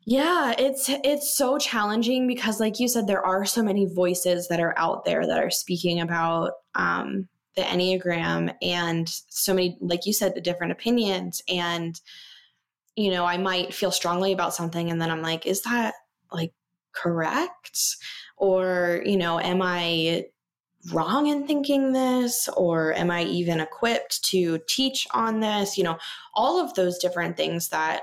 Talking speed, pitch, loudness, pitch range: 165 wpm, 185 Hz, -24 LUFS, 170-230 Hz